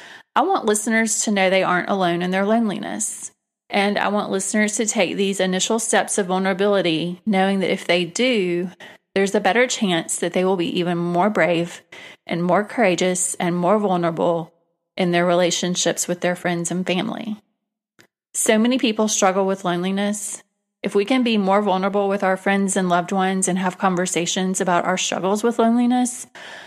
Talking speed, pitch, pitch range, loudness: 175 wpm, 190 Hz, 180-210 Hz, -20 LUFS